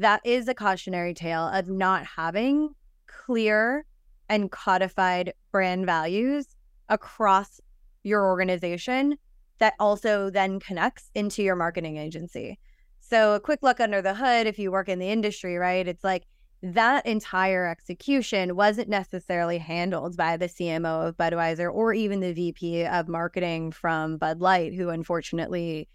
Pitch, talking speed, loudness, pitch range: 190 Hz, 145 wpm, -26 LUFS, 170-215 Hz